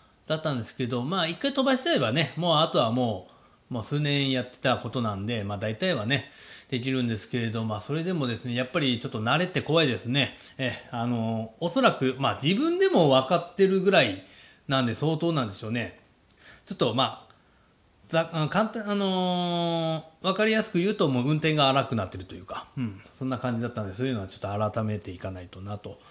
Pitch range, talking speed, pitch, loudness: 115-165 Hz, 420 characters per minute, 130 Hz, -26 LUFS